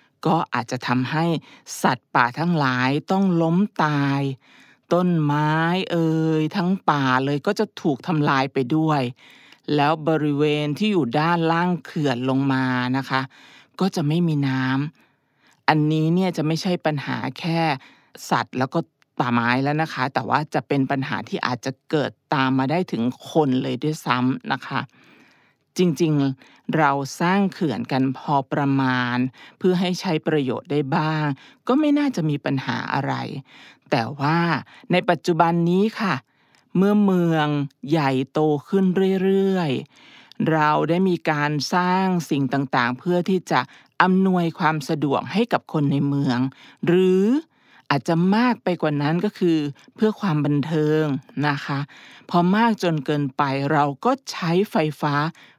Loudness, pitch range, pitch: -22 LUFS, 140-180 Hz, 155 Hz